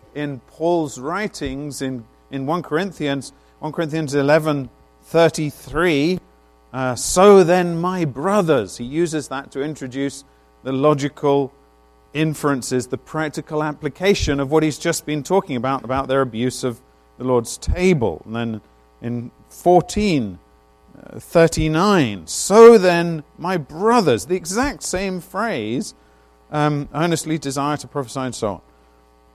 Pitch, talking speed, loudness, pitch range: 145 Hz, 125 wpm, -19 LUFS, 120-165 Hz